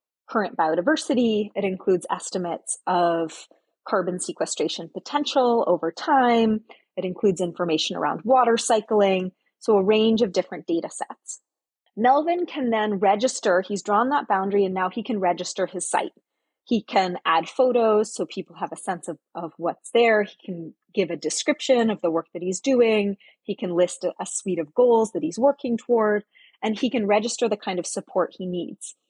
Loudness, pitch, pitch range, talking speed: -23 LUFS, 205 Hz, 180-235 Hz, 175 wpm